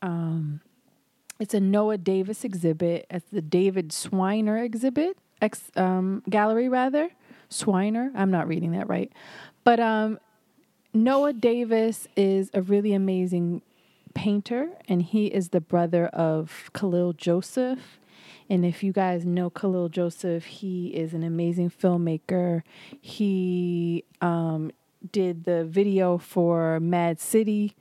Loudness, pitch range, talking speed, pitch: -25 LUFS, 175-215 Hz, 125 wpm, 185 Hz